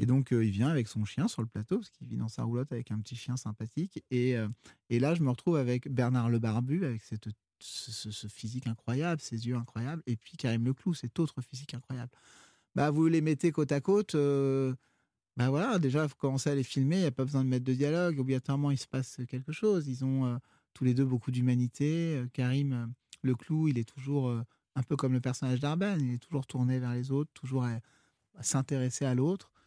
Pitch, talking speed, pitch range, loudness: 130 Hz, 235 wpm, 120-145 Hz, -32 LUFS